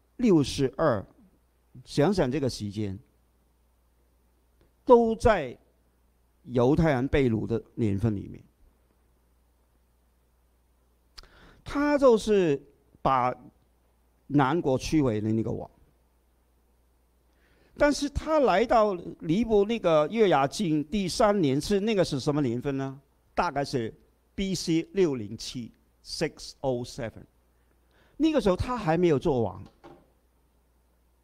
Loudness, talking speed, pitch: -26 LUFS, 160 characters per minute, 110 Hz